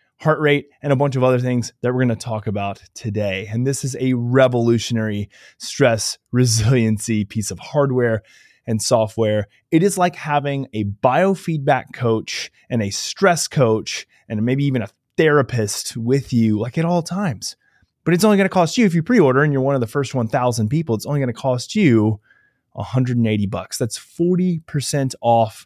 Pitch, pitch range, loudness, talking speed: 125 Hz, 110-145 Hz, -19 LUFS, 185 wpm